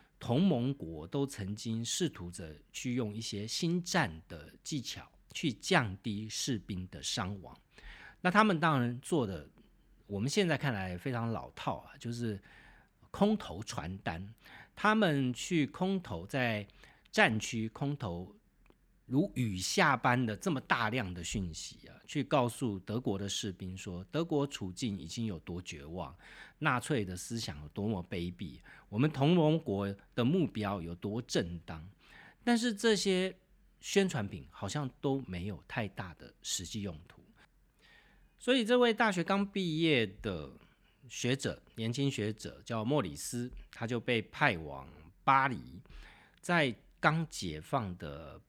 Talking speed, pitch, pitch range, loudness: 205 characters per minute, 115 Hz, 95-150 Hz, -34 LUFS